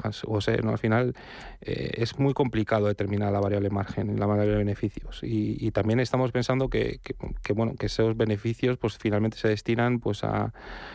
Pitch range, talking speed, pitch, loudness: 105-115 Hz, 190 wpm, 110 Hz, -27 LUFS